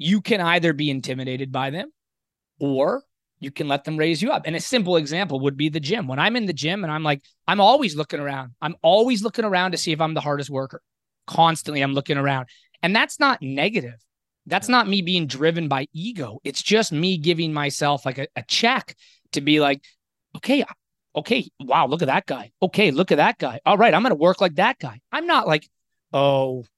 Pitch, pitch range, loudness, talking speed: 155 Hz, 140-185 Hz, -21 LUFS, 220 wpm